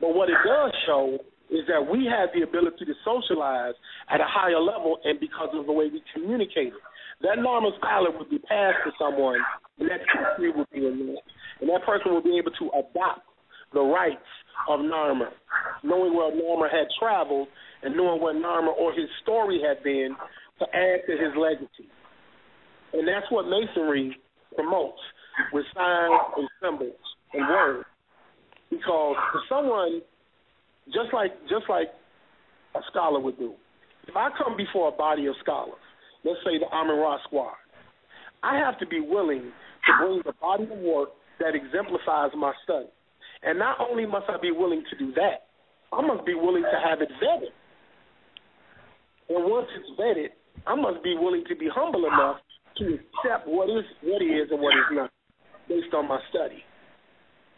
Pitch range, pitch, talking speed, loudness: 155-235 Hz, 175 Hz, 170 wpm, -26 LUFS